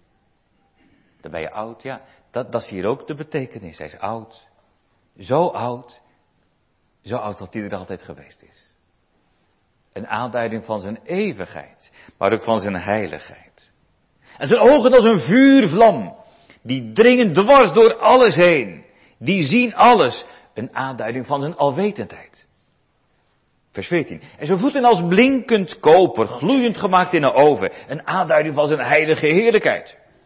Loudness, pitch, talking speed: -16 LUFS, 130 Hz, 145 wpm